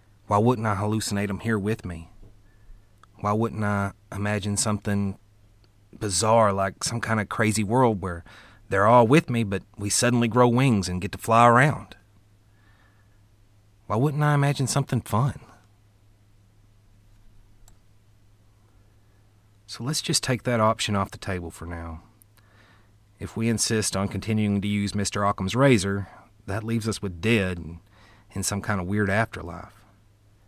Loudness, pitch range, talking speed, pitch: -24 LUFS, 100-110 Hz, 145 wpm, 105 Hz